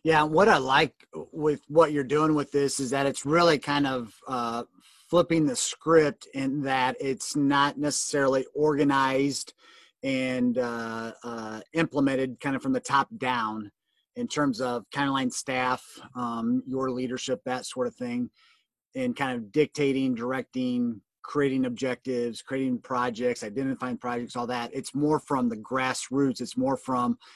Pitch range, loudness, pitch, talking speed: 125-145 Hz, -27 LUFS, 135 Hz, 155 wpm